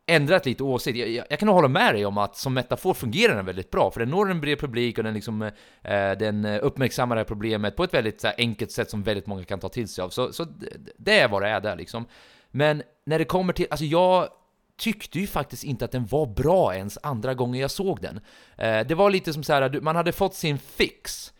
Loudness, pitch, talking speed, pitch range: -24 LUFS, 130 Hz, 250 wpm, 110-160 Hz